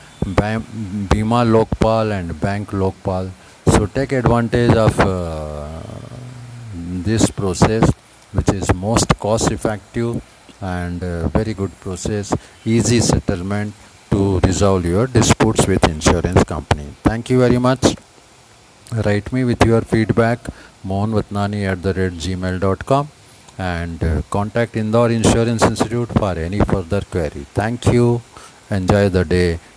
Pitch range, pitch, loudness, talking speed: 95-115 Hz, 105 Hz, -18 LUFS, 120 wpm